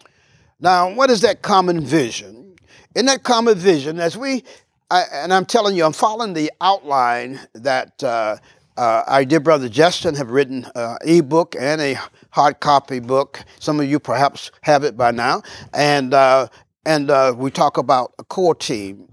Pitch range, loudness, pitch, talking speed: 135-180 Hz, -17 LUFS, 155 Hz, 175 wpm